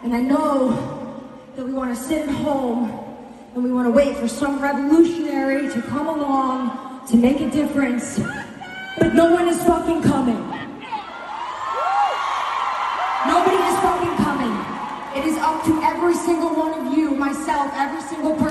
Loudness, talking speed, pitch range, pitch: -20 LUFS, 155 wpm, 260-315 Hz, 280 Hz